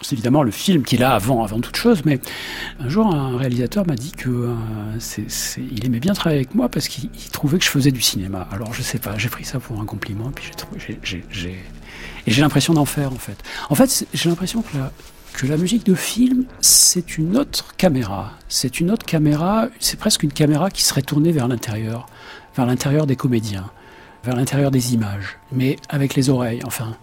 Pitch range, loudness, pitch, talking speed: 115-160 Hz, -19 LUFS, 135 Hz, 220 wpm